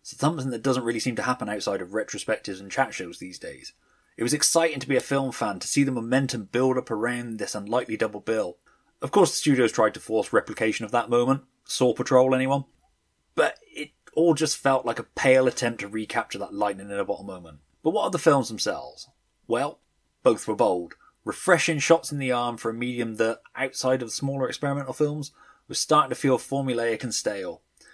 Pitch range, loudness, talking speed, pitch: 115-140 Hz, -25 LUFS, 210 wpm, 130 Hz